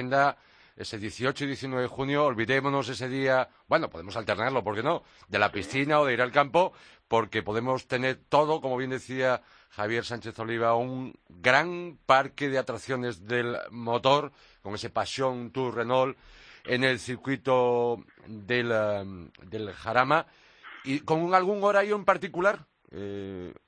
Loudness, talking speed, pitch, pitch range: -27 LUFS, 150 wpm, 130 Hz, 115-140 Hz